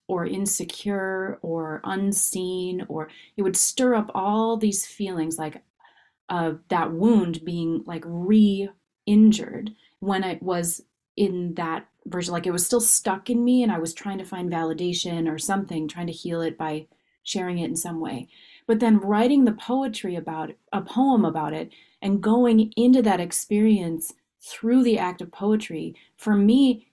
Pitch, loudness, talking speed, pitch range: 190 Hz, -23 LUFS, 165 wpm, 170-220 Hz